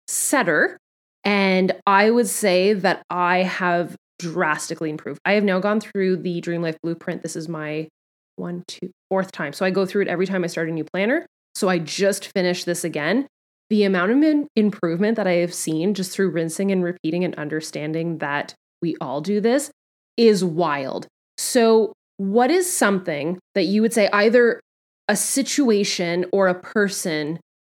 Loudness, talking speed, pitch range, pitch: -21 LUFS, 175 wpm, 170-205 Hz, 185 Hz